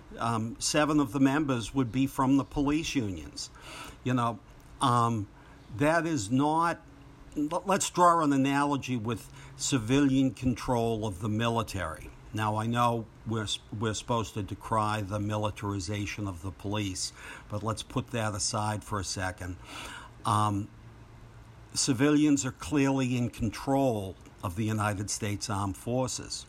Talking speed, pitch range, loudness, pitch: 135 wpm, 105-140 Hz, -29 LUFS, 115 Hz